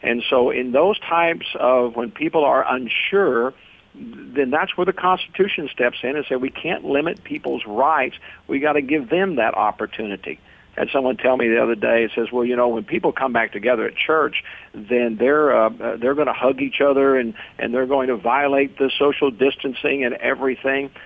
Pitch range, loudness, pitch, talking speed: 120-150 Hz, -20 LUFS, 135 Hz, 200 wpm